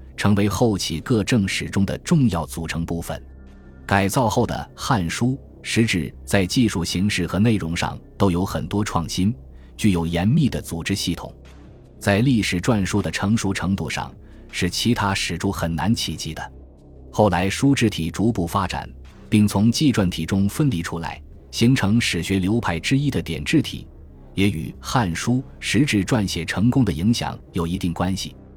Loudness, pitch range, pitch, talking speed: -21 LUFS, 85-110 Hz, 95 Hz, 245 characters per minute